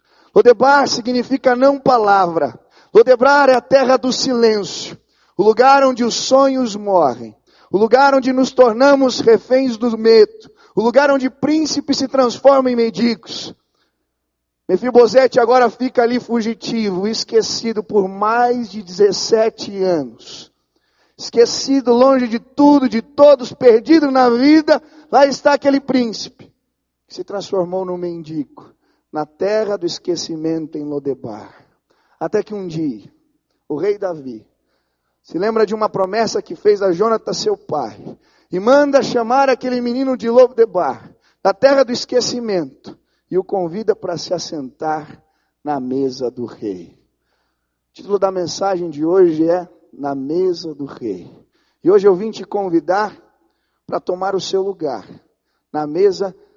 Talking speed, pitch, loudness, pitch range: 140 wpm, 230 Hz, -15 LUFS, 180-270 Hz